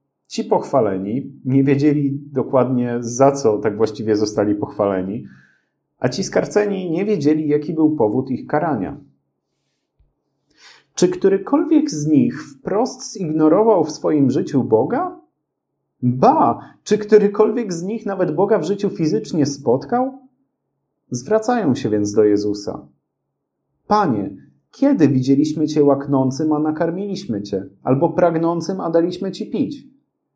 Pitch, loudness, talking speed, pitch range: 155 Hz, -18 LUFS, 120 wpm, 135-205 Hz